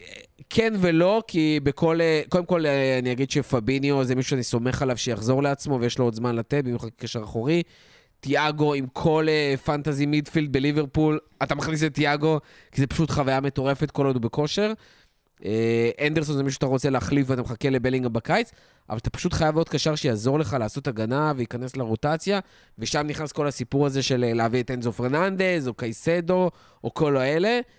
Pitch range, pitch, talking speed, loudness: 130-155 Hz, 140 Hz, 175 wpm, -24 LUFS